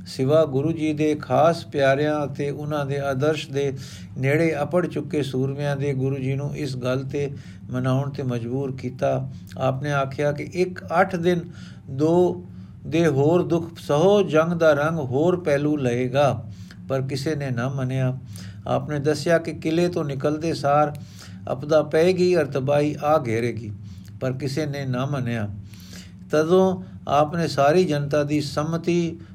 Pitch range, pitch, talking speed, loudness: 130-155 Hz, 145 Hz, 145 wpm, -23 LUFS